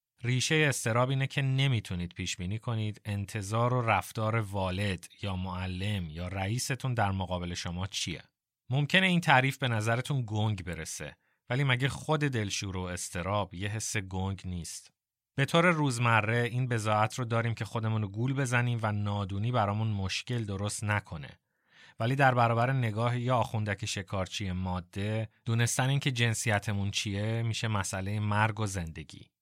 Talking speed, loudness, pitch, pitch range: 150 wpm, -30 LUFS, 110 Hz, 100-120 Hz